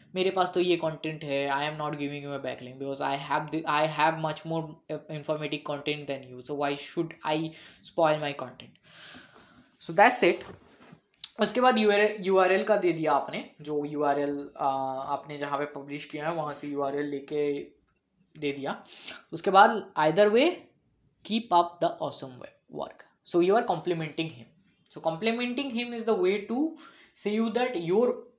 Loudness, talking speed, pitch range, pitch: -28 LUFS, 115 wpm, 145-200 Hz, 155 Hz